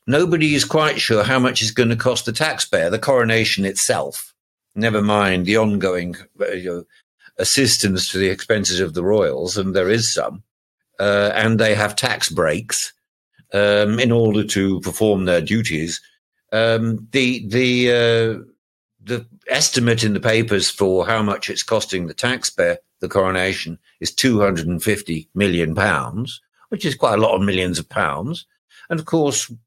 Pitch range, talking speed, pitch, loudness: 95-120 Hz, 165 wpm, 110 Hz, -18 LUFS